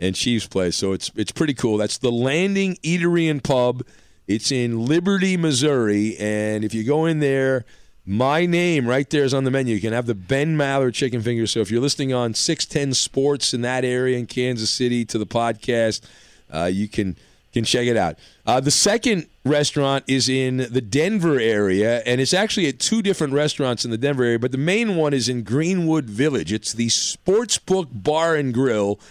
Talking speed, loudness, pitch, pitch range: 200 wpm, -20 LUFS, 130 Hz, 115-150 Hz